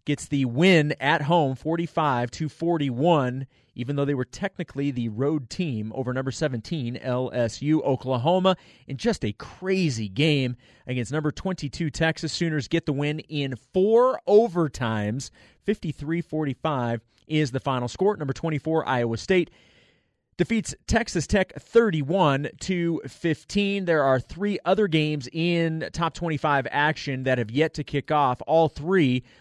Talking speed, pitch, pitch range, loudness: 140 wpm, 150 Hz, 130-170 Hz, -25 LUFS